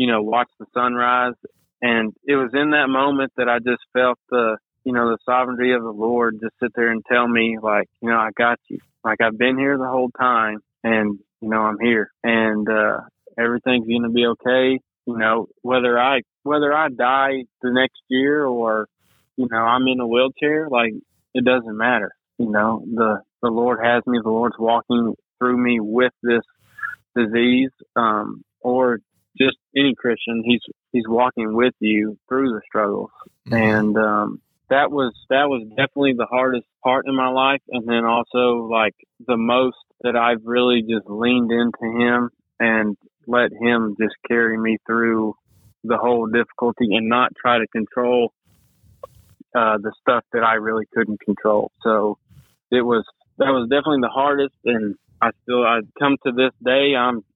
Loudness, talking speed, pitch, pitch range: -19 LUFS, 175 wpm, 120 Hz, 115-125 Hz